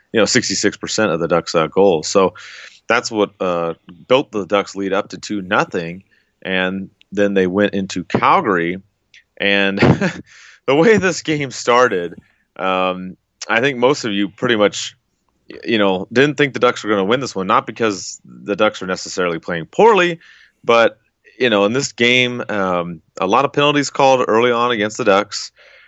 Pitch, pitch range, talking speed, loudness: 105 Hz, 95-125 Hz, 180 wpm, -16 LUFS